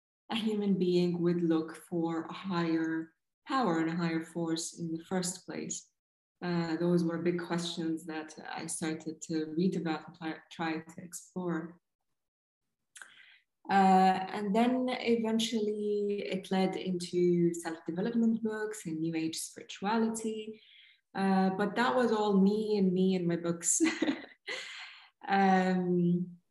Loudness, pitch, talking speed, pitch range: -32 LUFS, 180 Hz, 135 wpm, 165-205 Hz